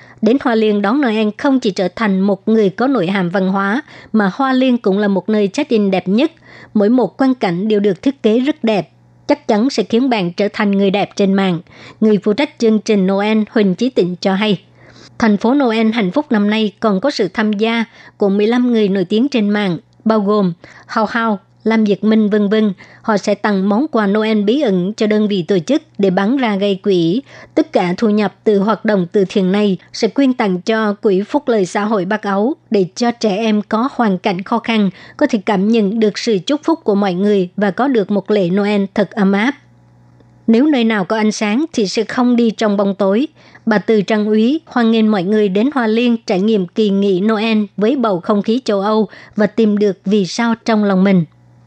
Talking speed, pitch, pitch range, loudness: 230 wpm, 215 Hz, 200-230 Hz, -15 LUFS